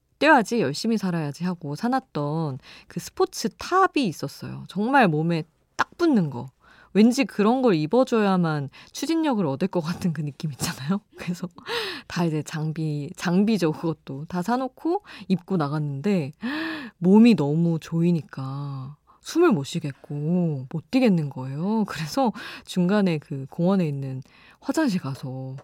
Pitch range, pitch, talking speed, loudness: 150-230 Hz, 175 Hz, 285 characters per minute, -24 LUFS